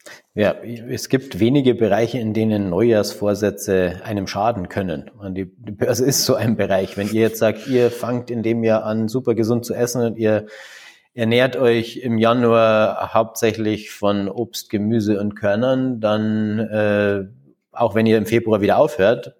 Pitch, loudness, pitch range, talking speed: 110 Hz, -19 LUFS, 105-120 Hz, 165 wpm